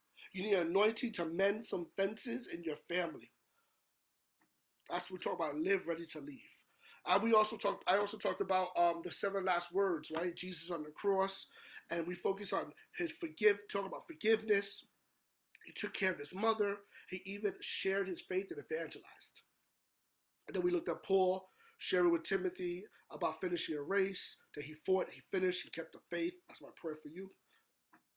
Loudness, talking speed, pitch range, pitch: -37 LUFS, 185 wpm, 175-205 Hz, 190 Hz